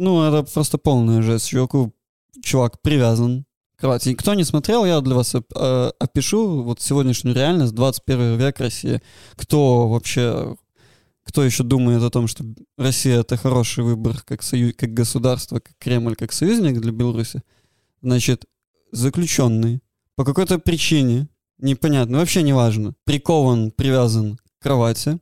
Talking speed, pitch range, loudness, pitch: 135 wpm, 120-140 Hz, -19 LUFS, 125 Hz